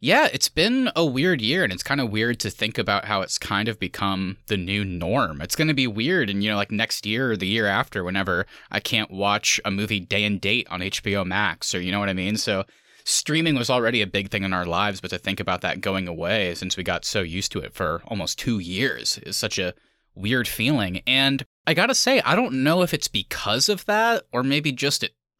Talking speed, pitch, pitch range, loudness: 250 wpm, 105 Hz, 95-130 Hz, -23 LUFS